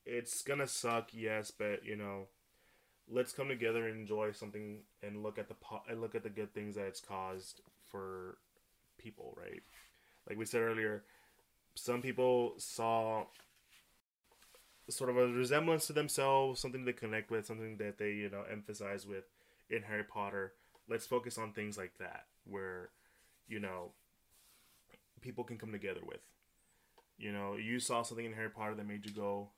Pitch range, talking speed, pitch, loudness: 105-120 Hz, 170 wpm, 110 Hz, -40 LUFS